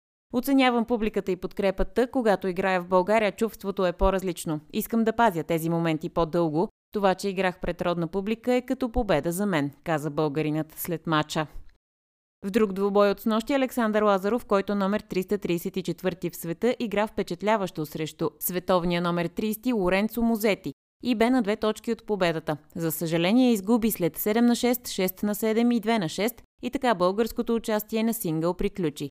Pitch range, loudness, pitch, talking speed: 170-225 Hz, -26 LUFS, 195 Hz, 165 wpm